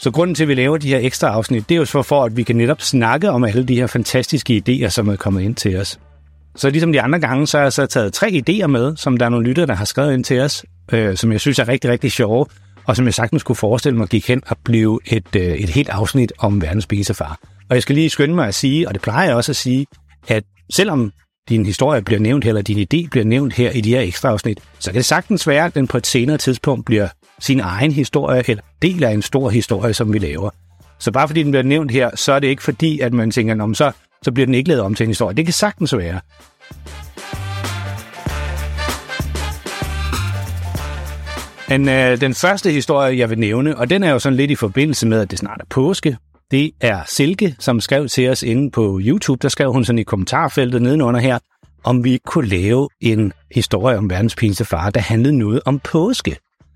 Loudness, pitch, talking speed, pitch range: -17 LUFS, 120 Hz, 235 wpm, 105-140 Hz